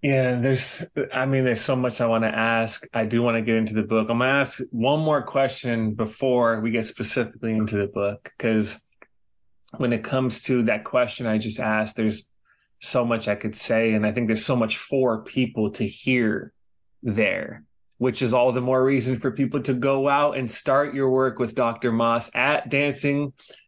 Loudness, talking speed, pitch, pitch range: -23 LUFS, 205 wpm, 125 Hz, 115-130 Hz